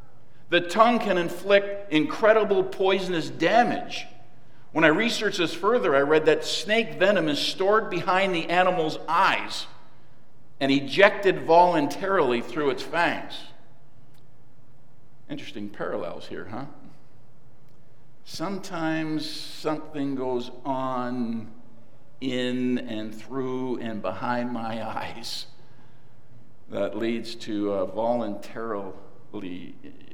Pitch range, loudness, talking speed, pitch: 125-175 Hz, -25 LUFS, 100 wpm, 140 Hz